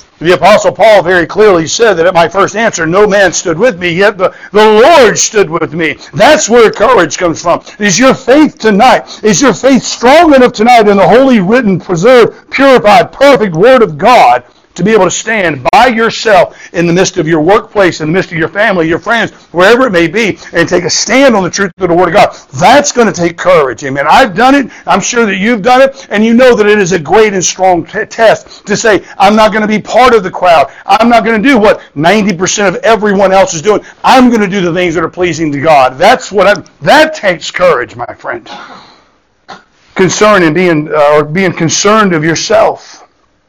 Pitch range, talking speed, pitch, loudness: 175-235 Hz, 225 wpm, 205 Hz, -7 LUFS